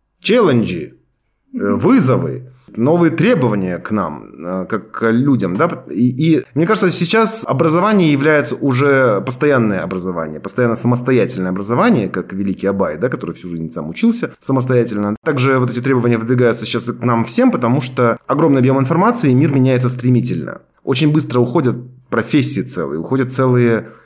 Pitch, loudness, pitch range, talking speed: 125 Hz, -15 LUFS, 115-145 Hz, 145 wpm